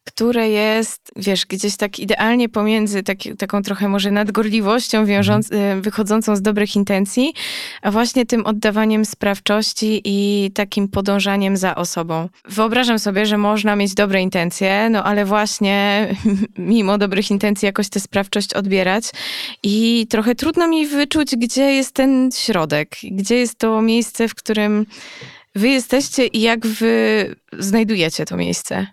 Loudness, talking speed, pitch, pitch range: -17 LUFS, 140 wpm, 210 Hz, 200-225 Hz